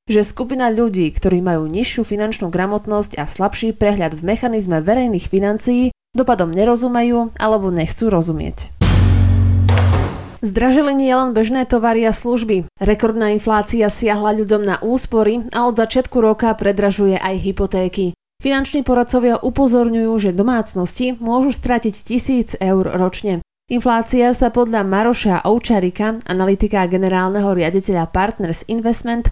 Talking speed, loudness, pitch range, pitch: 120 wpm, -16 LUFS, 190-240 Hz, 215 Hz